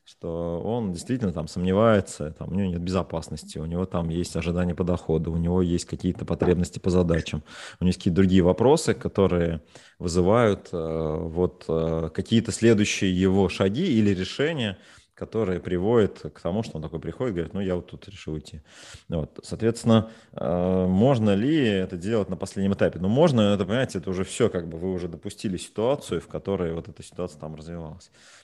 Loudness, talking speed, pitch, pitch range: -25 LUFS, 175 wpm, 90 Hz, 85-100 Hz